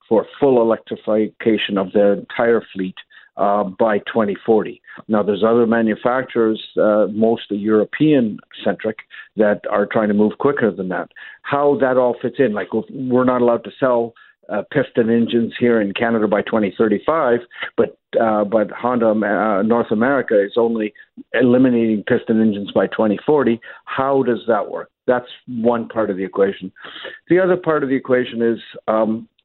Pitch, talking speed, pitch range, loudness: 115 Hz, 155 wpm, 105-125 Hz, -18 LUFS